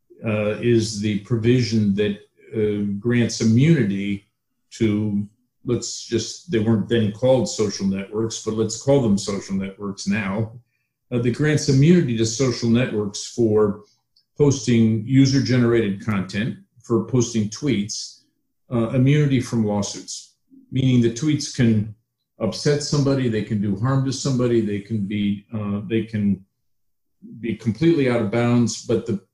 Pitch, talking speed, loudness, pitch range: 115 Hz, 140 wpm, -21 LUFS, 105-125 Hz